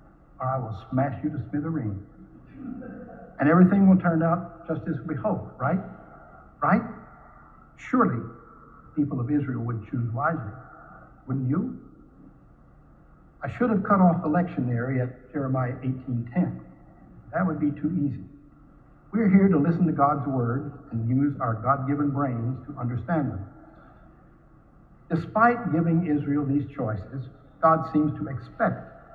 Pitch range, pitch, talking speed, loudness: 130-165 Hz, 145 Hz, 140 wpm, -25 LUFS